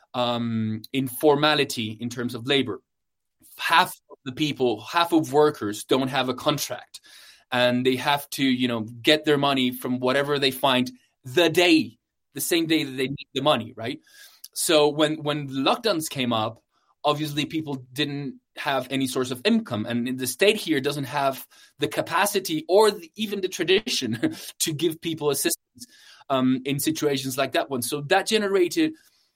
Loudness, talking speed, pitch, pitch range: -24 LUFS, 165 wpm, 145 Hz, 130-165 Hz